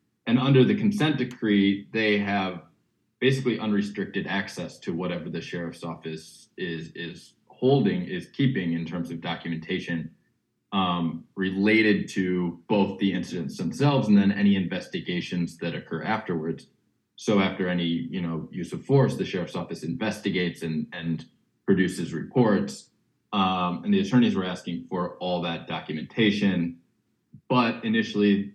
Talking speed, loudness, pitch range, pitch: 140 wpm, -26 LUFS, 85-115 Hz, 100 Hz